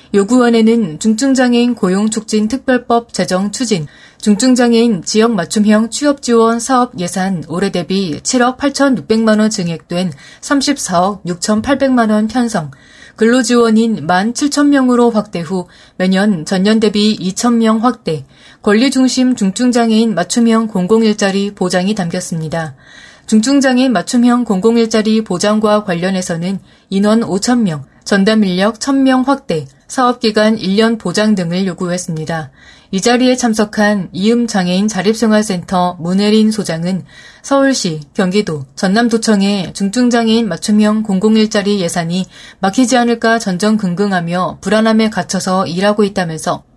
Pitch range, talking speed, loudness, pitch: 185-235 Hz, 290 characters per minute, -13 LUFS, 215 Hz